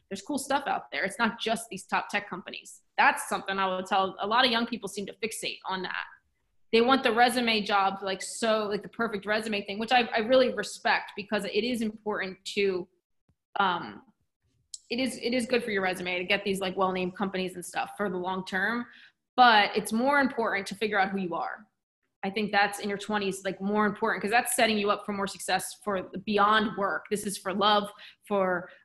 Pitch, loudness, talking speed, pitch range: 205 Hz, -28 LUFS, 220 wpm, 195-225 Hz